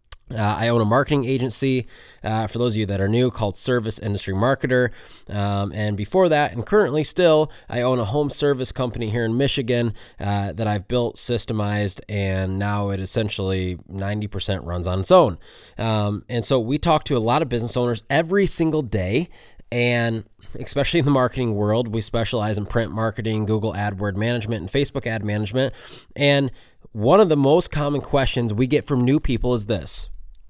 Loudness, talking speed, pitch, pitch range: -21 LUFS, 185 wpm, 115 Hz, 105-130 Hz